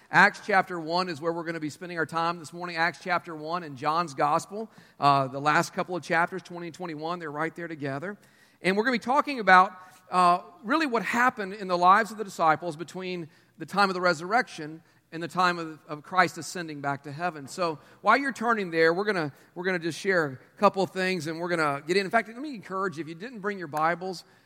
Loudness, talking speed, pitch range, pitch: -27 LUFS, 250 wpm, 165-190 Hz, 175 Hz